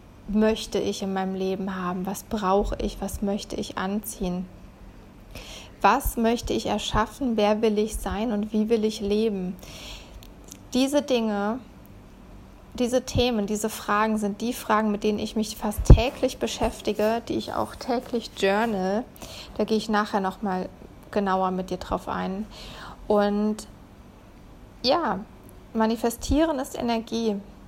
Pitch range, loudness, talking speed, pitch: 200-230 Hz, -26 LUFS, 135 wpm, 215 Hz